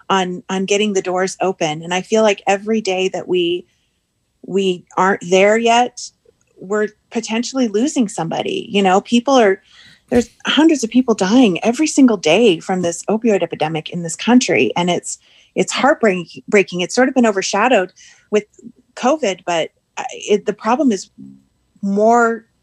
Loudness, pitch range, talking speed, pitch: -16 LUFS, 185-235 Hz, 155 wpm, 205 Hz